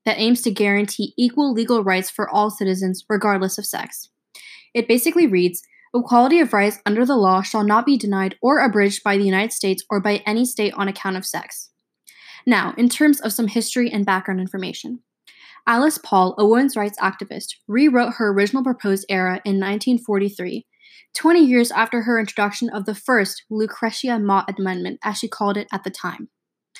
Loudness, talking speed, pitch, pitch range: -19 LUFS, 180 wpm, 210 Hz, 195-240 Hz